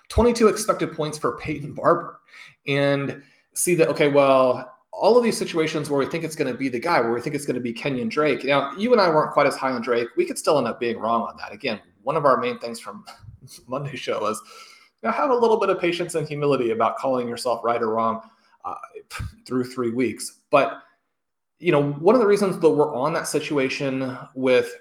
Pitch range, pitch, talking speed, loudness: 125-170 Hz, 145 Hz, 230 wpm, -22 LUFS